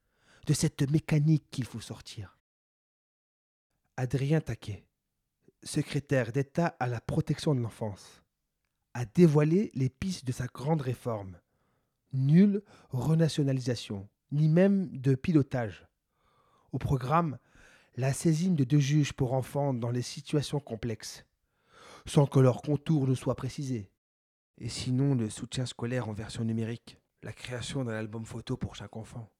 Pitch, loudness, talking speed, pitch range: 130 Hz, -30 LUFS, 135 wpm, 115-145 Hz